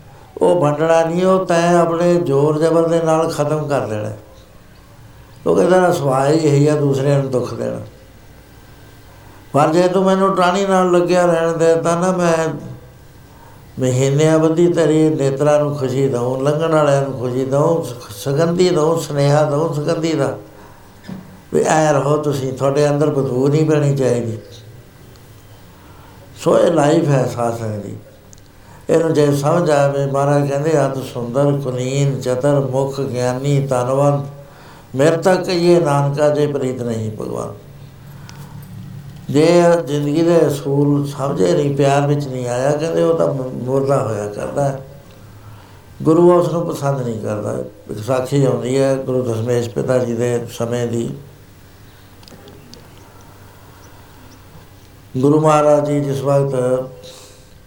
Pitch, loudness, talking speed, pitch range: 135 Hz, -16 LUFS, 130 wpm, 120-150 Hz